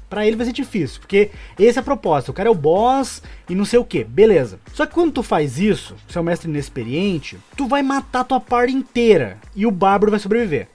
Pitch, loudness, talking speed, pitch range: 215 Hz, -18 LUFS, 235 wpm, 175-255 Hz